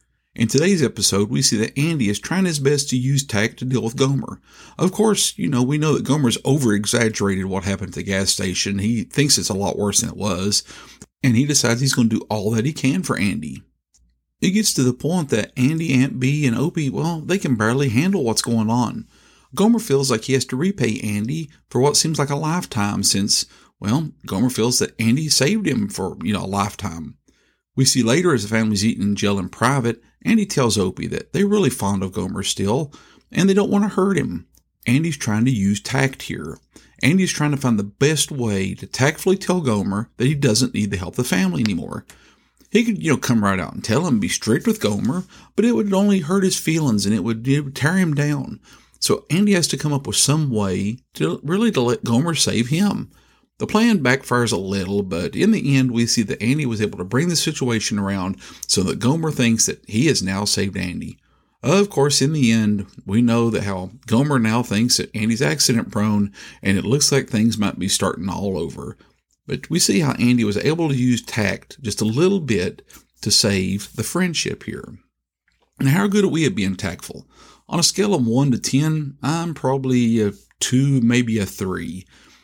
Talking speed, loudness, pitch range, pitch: 215 wpm, -19 LUFS, 105-150 Hz, 125 Hz